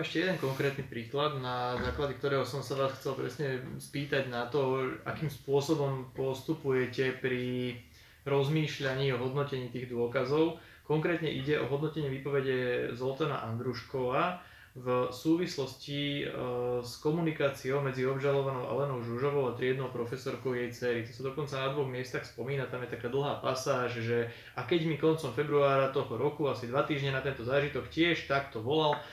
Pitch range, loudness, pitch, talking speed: 125-145 Hz, -33 LUFS, 135 Hz, 150 wpm